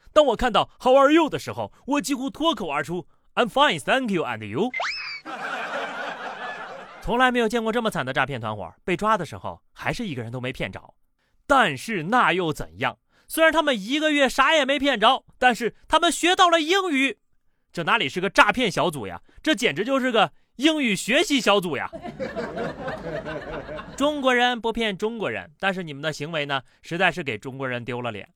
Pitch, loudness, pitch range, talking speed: 230 Hz, -23 LUFS, 170-280 Hz, 310 characters per minute